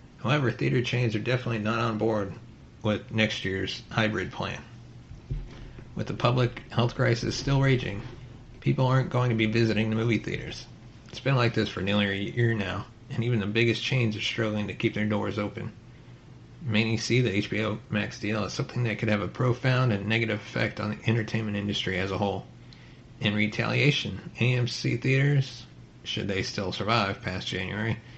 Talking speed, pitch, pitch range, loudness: 175 wpm, 115 Hz, 105-125 Hz, -27 LUFS